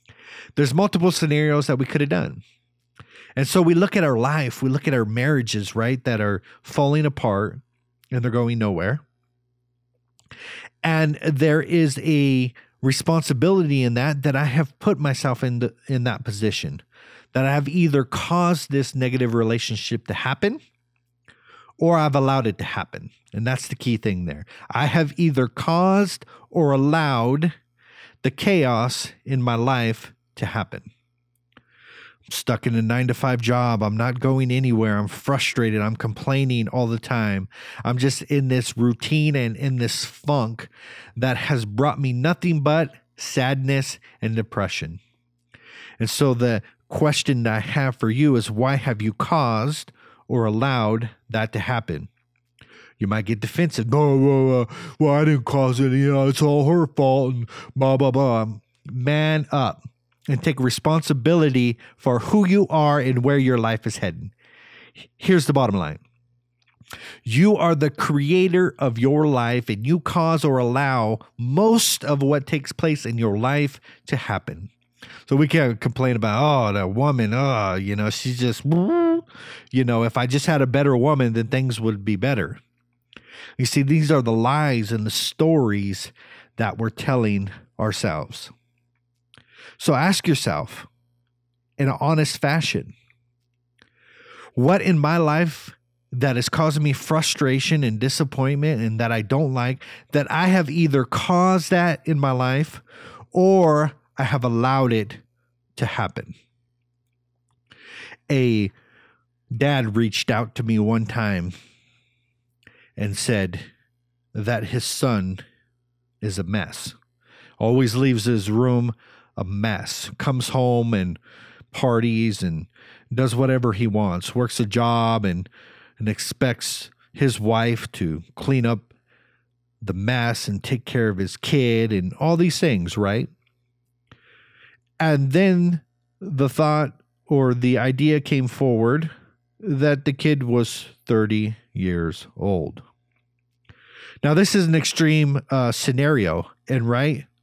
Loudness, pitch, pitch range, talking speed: -21 LUFS, 125 Hz, 115-145 Hz, 145 wpm